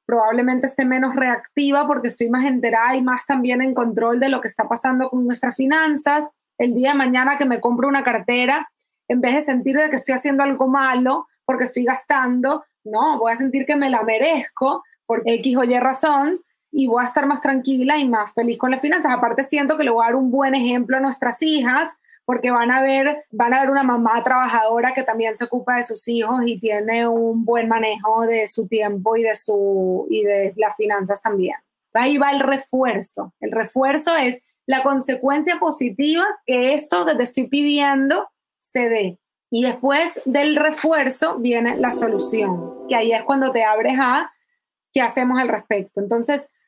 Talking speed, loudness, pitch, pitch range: 195 wpm, -18 LUFS, 255 Hz, 230-280 Hz